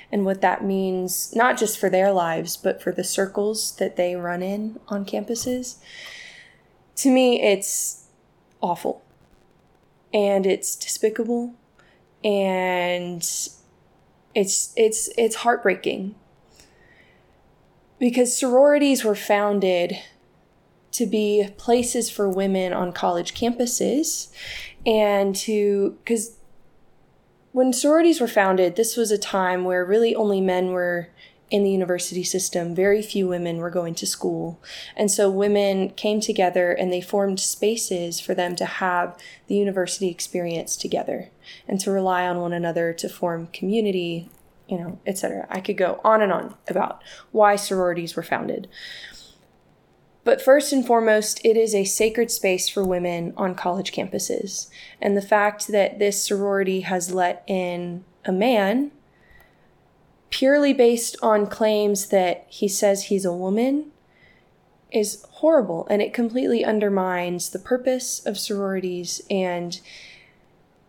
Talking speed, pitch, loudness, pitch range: 135 wpm, 200 Hz, -22 LUFS, 180-225 Hz